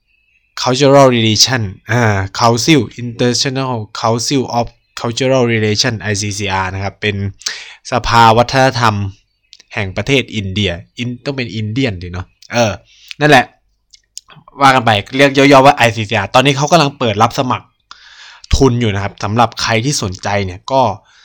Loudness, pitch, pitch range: -13 LUFS, 115 Hz, 105-130 Hz